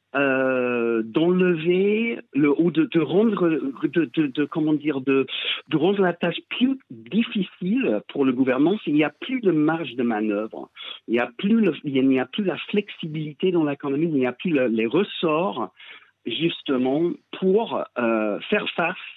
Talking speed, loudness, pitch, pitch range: 175 wpm, -23 LUFS, 165 Hz, 135-205 Hz